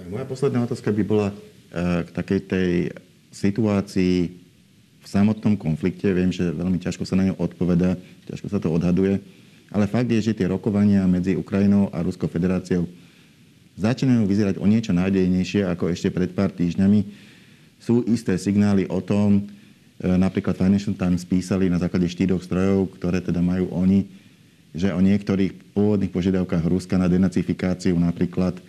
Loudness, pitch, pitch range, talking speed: -22 LUFS, 95 Hz, 90-100 Hz, 150 wpm